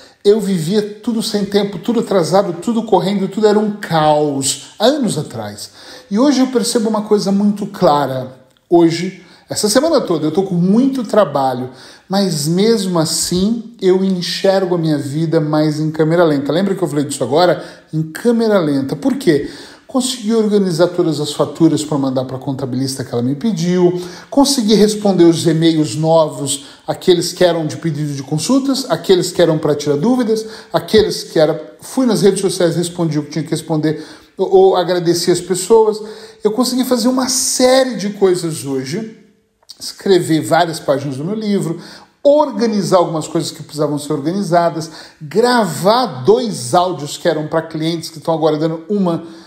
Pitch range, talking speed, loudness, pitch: 155-210 Hz, 165 wpm, -15 LUFS, 175 Hz